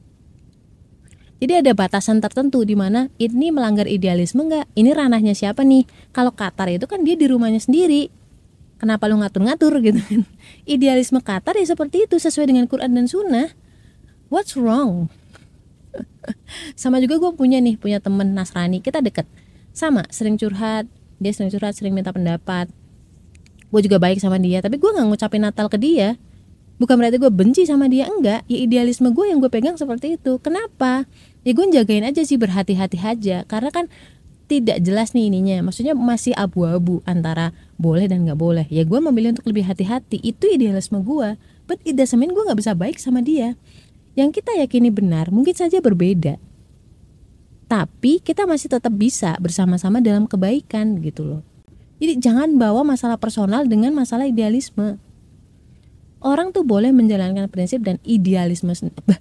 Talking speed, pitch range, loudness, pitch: 160 wpm, 200-270 Hz, -18 LUFS, 230 Hz